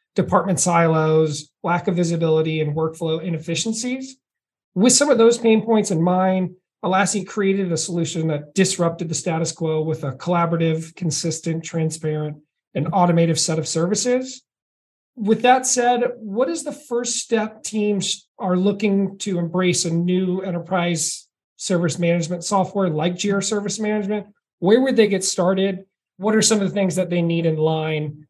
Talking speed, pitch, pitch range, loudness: 155 wpm, 185 Hz, 165-210 Hz, -20 LUFS